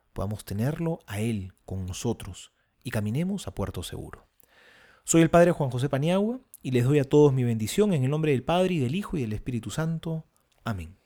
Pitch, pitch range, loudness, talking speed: 130 Hz, 105-165 Hz, -26 LUFS, 200 wpm